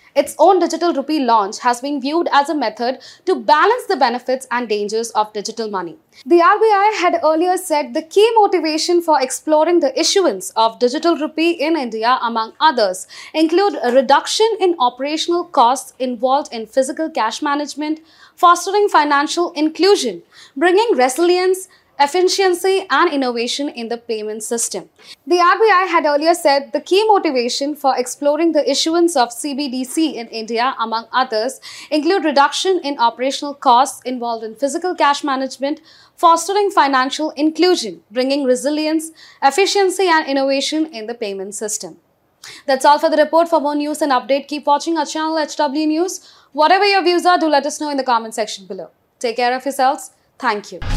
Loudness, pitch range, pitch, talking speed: -16 LUFS, 255-340 Hz, 295 Hz, 160 wpm